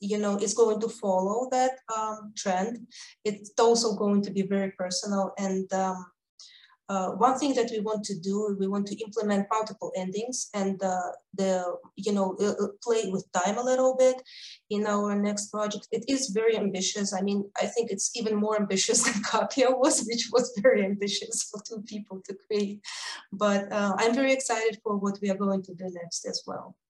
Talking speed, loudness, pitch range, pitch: 190 wpm, -27 LUFS, 195-225 Hz, 210 Hz